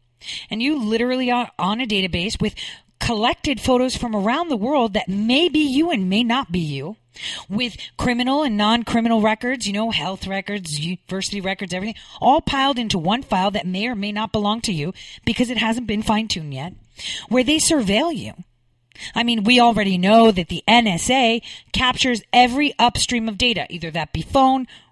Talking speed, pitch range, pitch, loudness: 185 wpm, 190-245 Hz, 220 Hz, -19 LUFS